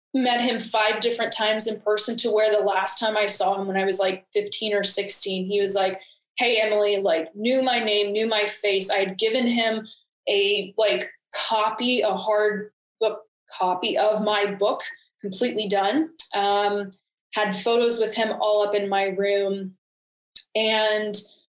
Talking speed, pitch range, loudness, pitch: 170 wpm, 200-220 Hz, -22 LUFS, 210 Hz